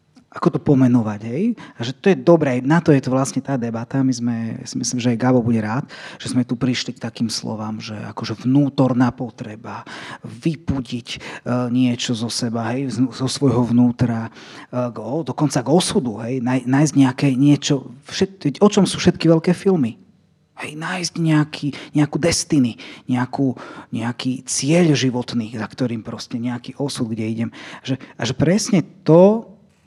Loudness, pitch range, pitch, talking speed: -19 LUFS, 120-155 Hz, 130 Hz, 165 wpm